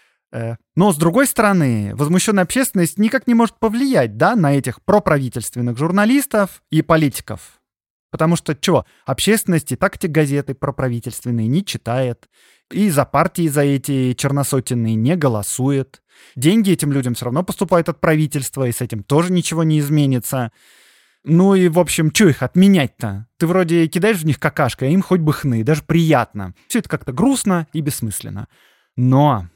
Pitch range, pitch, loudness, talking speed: 130-180 Hz, 155 Hz, -17 LUFS, 160 wpm